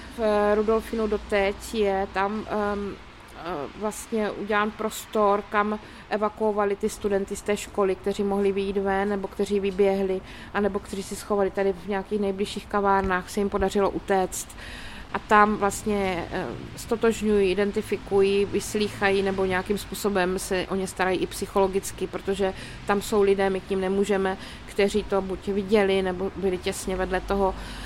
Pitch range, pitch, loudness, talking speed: 195-205 Hz, 200 Hz, -25 LUFS, 145 wpm